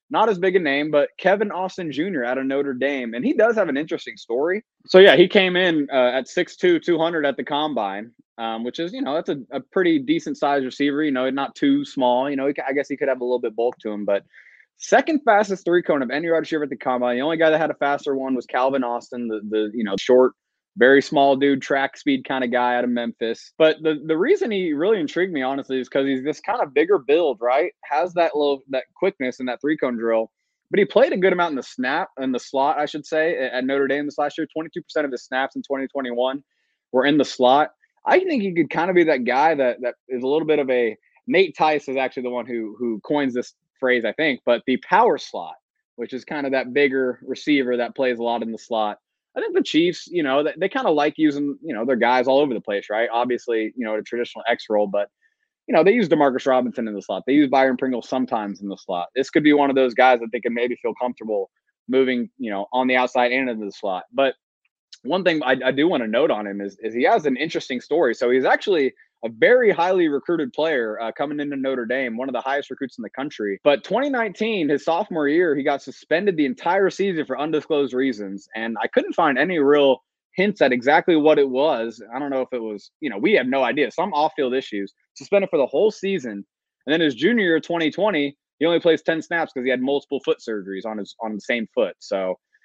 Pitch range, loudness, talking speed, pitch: 125-165 Hz, -21 LUFS, 250 wpm, 140 Hz